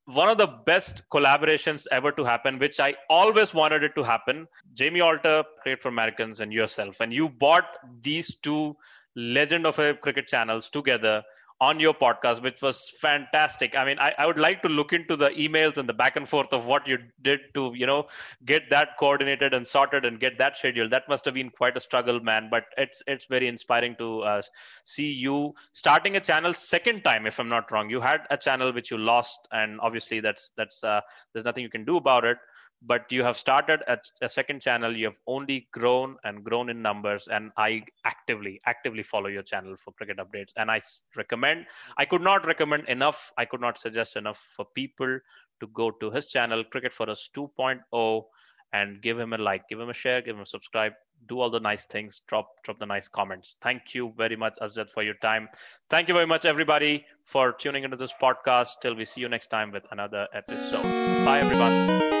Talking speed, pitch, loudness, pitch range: 210 wpm, 125 Hz, -25 LUFS, 115-145 Hz